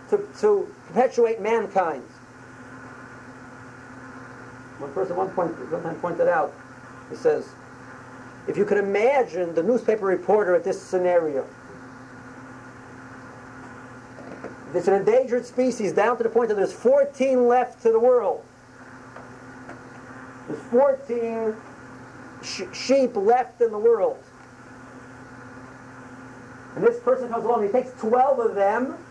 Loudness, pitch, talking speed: -22 LUFS, 180 Hz, 120 wpm